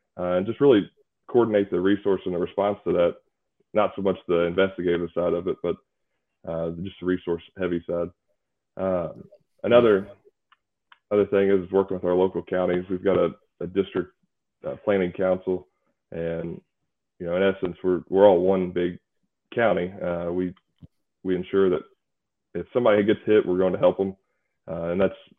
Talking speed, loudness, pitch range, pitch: 170 wpm, -24 LUFS, 85-95 Hz, 90 Hz